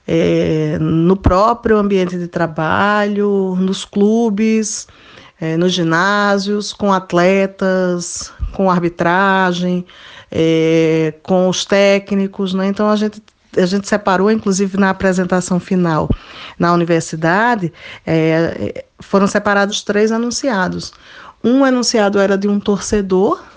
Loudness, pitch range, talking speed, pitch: -15 LUFS, 175-205 Hz, 110 wpm, 195 Hz